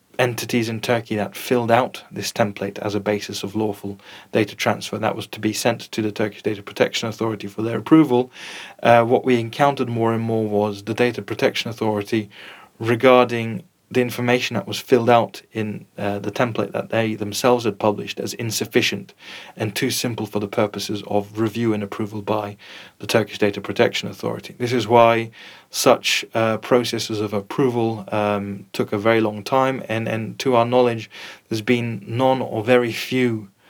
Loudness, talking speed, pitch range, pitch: -21 LUFS, 180 wpm, 105-120 Hz, 115 Hz